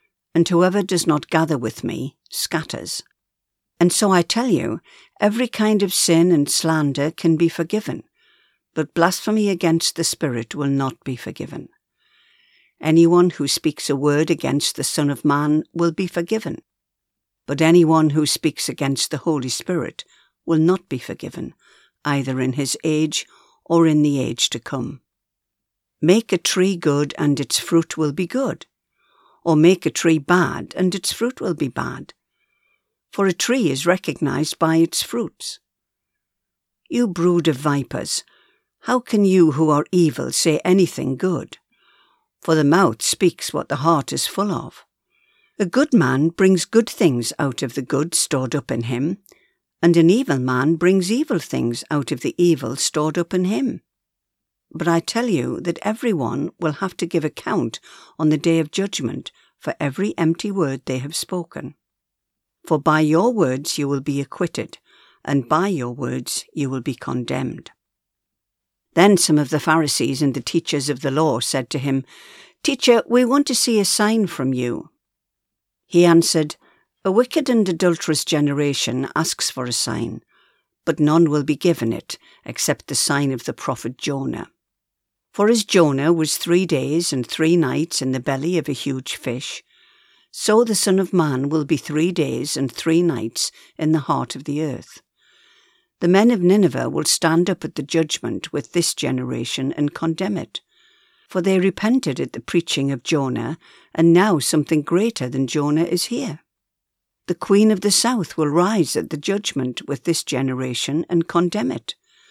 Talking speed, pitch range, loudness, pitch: 170 wpm, 140-180 Hz, -19 LUFS, 160 Hz